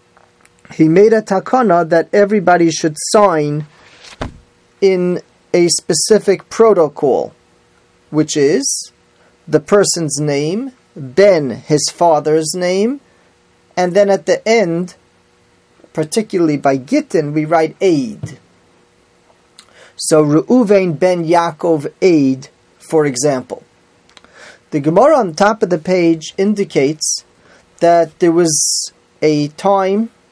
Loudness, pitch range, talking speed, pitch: -13 LUFS, 150-200 Hz, 105 wpm, 170 Hz